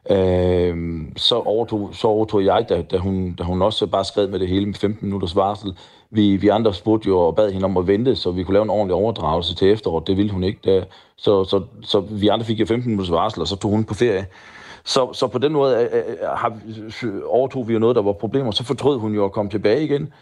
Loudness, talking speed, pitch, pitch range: -20 LUFS, 250 wpm, 105 Hz, 95-110 Hz